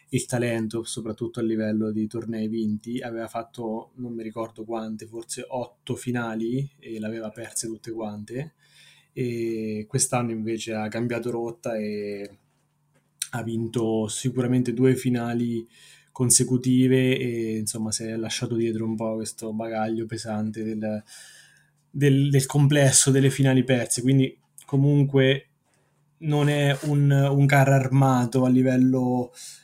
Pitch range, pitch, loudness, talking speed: 110-130 Hz, 120 Hz, -24 LUFS, 130 wpm